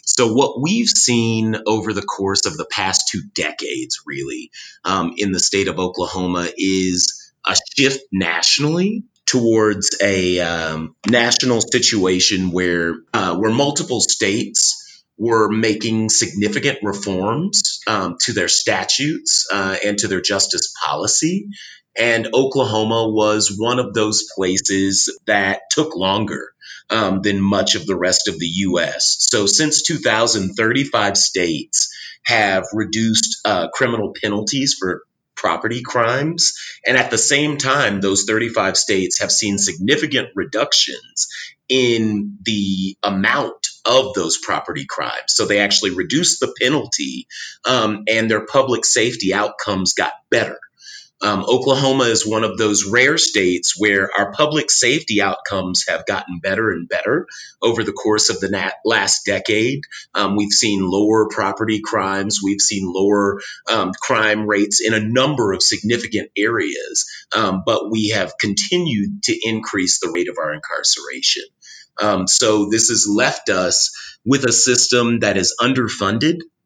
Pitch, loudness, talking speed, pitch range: 110 Hz, -17 LUFS, 140 wpm, 100-125 Hz